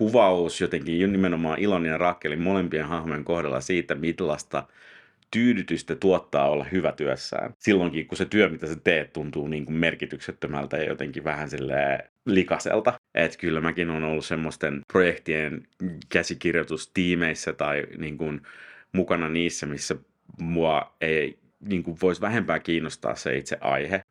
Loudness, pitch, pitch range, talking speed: -26 LUFS, 85 Hz, 80-90 Hz, 135 wpm